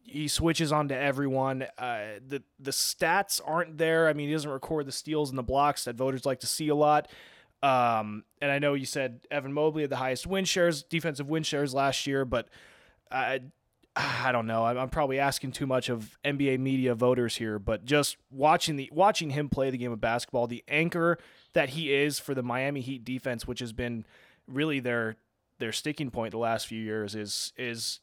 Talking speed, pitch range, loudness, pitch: 210 wpm, 120-150 Hz, -29 LUFS, 135 Hz